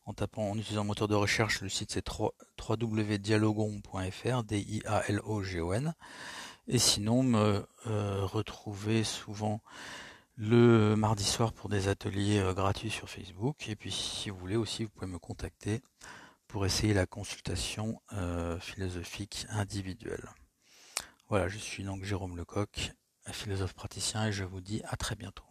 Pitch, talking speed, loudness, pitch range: 105 Hz, 135 wpm, -33 LUFS, 95-110 Hz